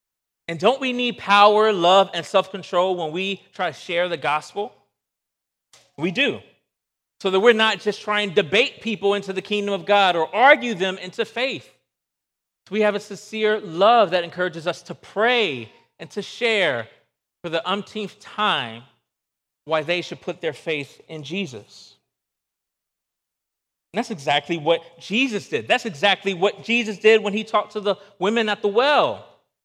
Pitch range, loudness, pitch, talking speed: 175-215 Hz, -21 LUFS, 200 Hz, 165 wpm